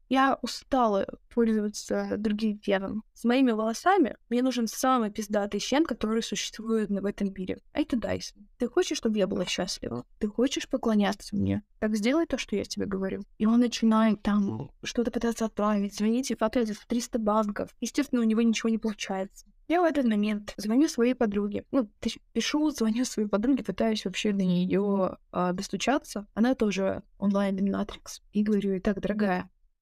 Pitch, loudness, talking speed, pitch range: 220 Hz, -28 LUFS, 165 wpm, 200-245 Hz